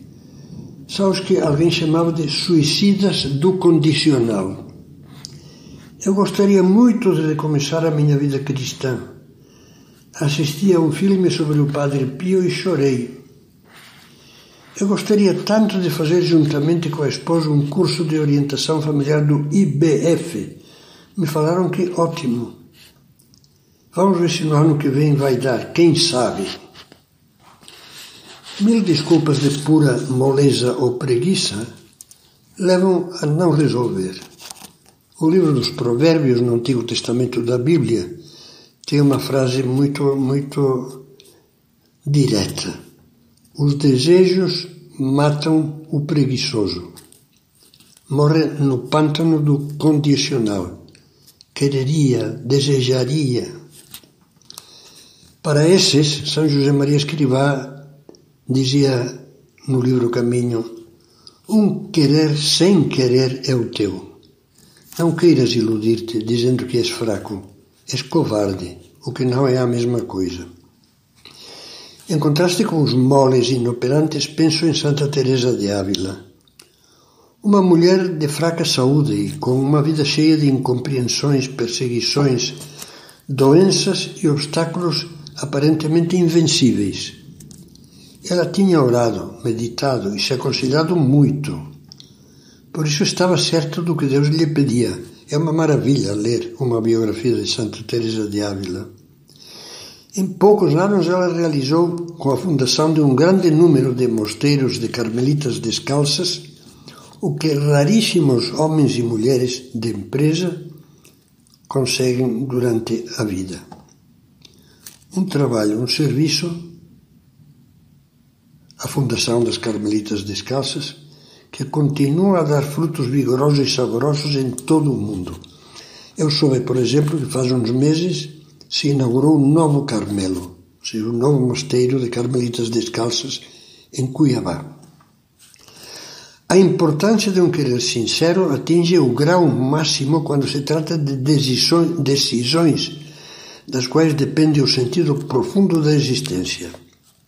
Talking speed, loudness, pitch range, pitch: 115 wpm, -17 LUFS, 125-160 Hz, 140 Hz